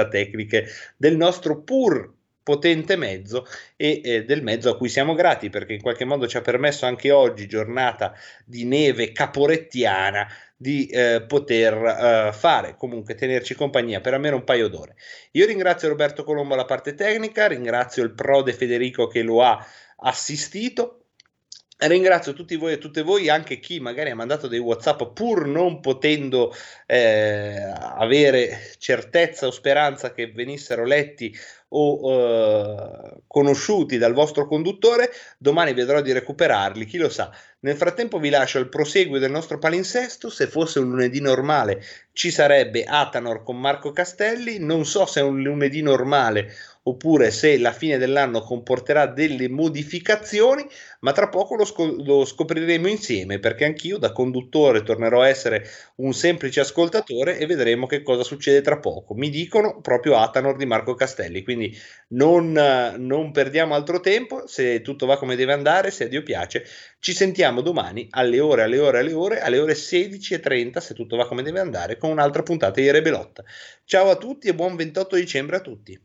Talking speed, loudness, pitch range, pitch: 160 wpm, -21 LUFS, 125-170 Hz, 145 Hz